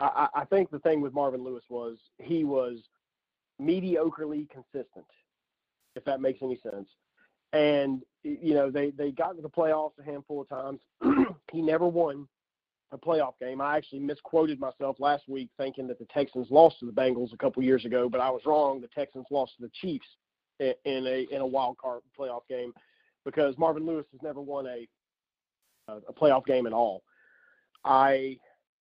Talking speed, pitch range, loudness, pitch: 180 wpm, 130-155 Hz, -29 LUFS, 140 Hz